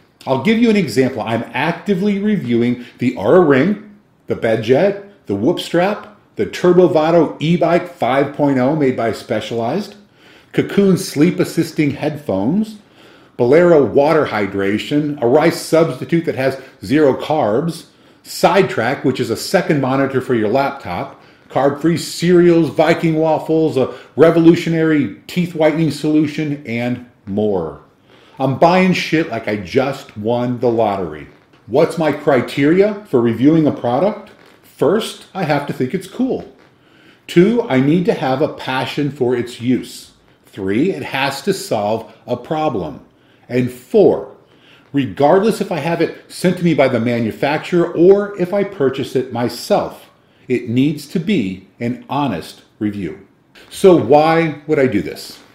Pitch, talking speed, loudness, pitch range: 150 Hz, 135 wpm, -16 LUFS, 125-170 Hz